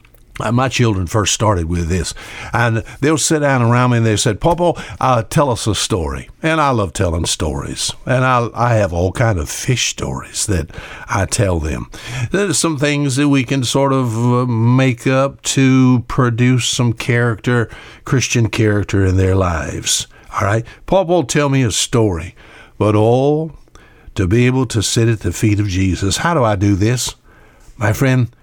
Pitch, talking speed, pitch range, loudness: 120 Hz, 180 wpm, 105-130 Hz, -16 LUFS